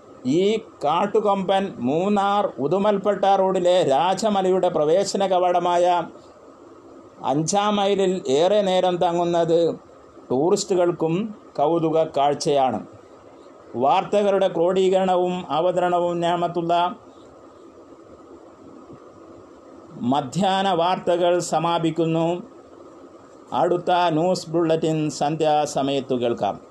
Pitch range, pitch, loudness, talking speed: 165-195 Hz, 180 Hz, -21 LUFS, 65 wpm